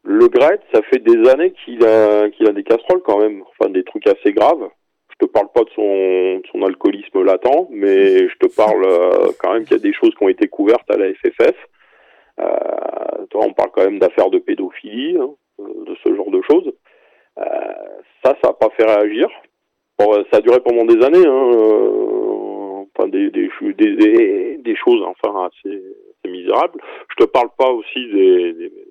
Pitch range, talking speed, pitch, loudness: 310-390 Hz, 190 wpm, 360 Hz, -15 LUFS